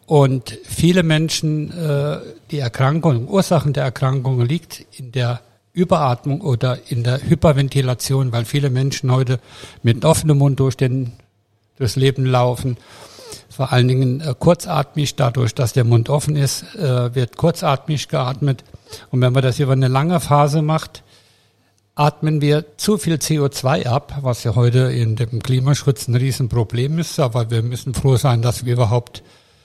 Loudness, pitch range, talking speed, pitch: -18 LUFS, 120-150 Hz, 150 wpm, 130 Hz